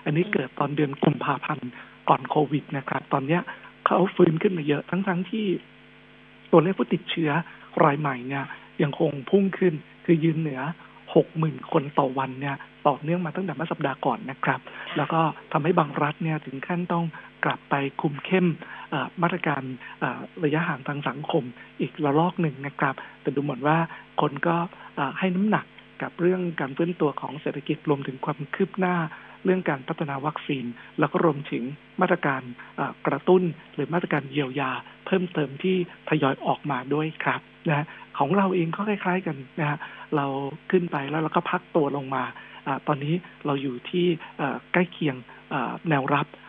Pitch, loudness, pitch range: 155 Hz, -26 LUFS, 140-175 Hz